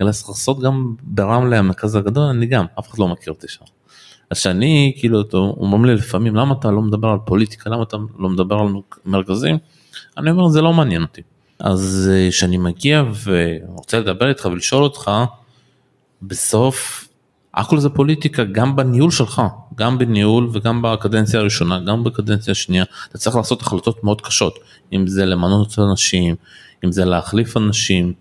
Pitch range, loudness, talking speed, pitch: 95-125 Hz, -17 LUFS, 165 wpm, 110 Hz